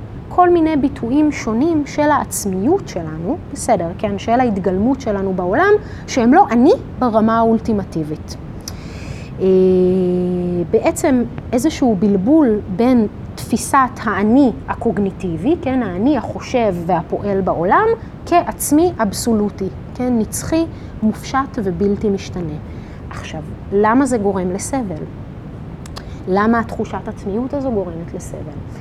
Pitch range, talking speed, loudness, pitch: 190-270 Hz, 100 wpm, -17 LUFS, 225 Hz